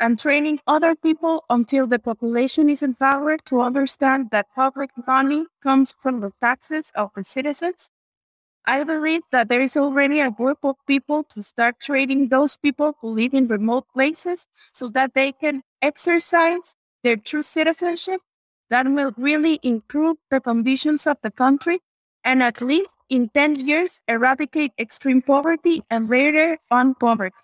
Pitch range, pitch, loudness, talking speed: 250-305 Hz, 275 Hz, -20 LUFS, 155 wpm